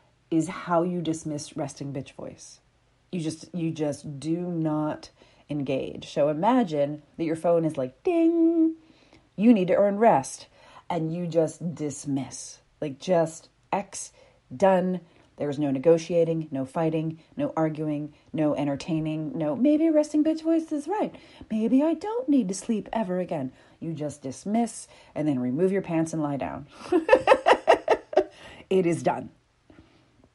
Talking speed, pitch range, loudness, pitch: 145 wpm, 150-220 Hz, -26 LUFS, 165 Hz